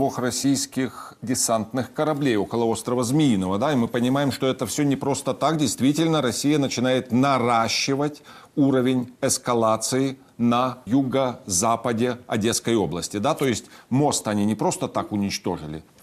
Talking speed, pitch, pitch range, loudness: 135 wpm, 125 Hz, 115-135 Hz, -23 LUFS